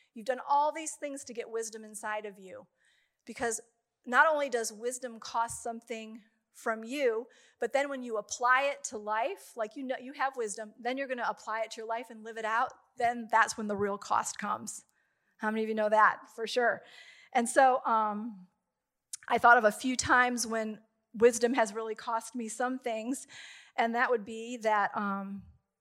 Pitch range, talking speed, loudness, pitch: 220-255 Hz, 200 wpm, -31 LUFS, 230 Hz